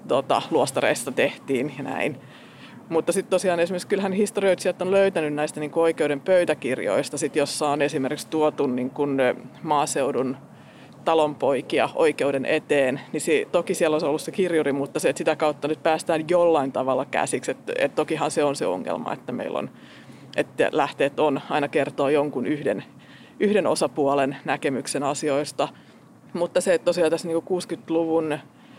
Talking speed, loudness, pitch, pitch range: 140 wpm, -24 LUFS, 165 Hz, 150-180 Hz